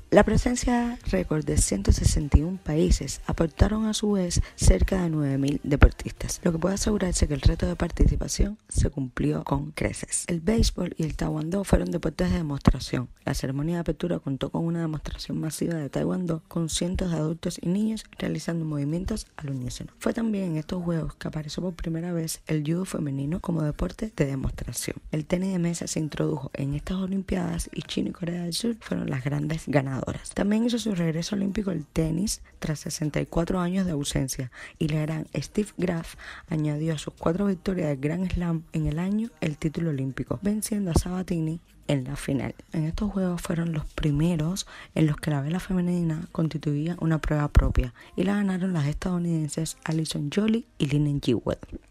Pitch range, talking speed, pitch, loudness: 150-185 Hz, 180 wpm, 165 Hz, -27 LUFS